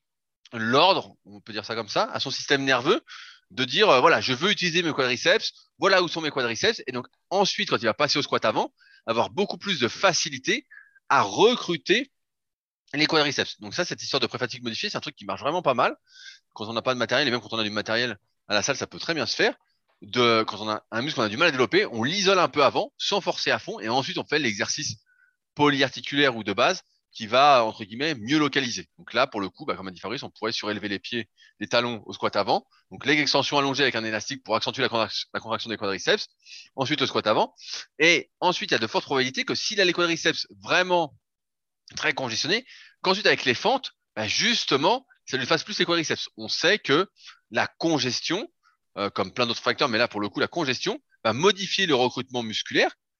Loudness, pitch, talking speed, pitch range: -24 LUFS, 135 Hz, 230 wpm, 115-180 Hz